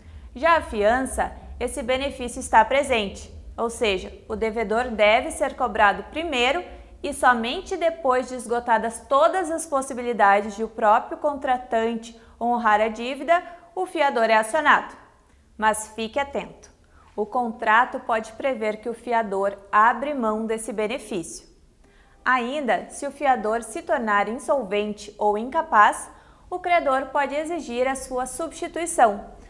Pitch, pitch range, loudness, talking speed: 245 Hz, 220-285 Hz, -23 LUFS, 130 wpm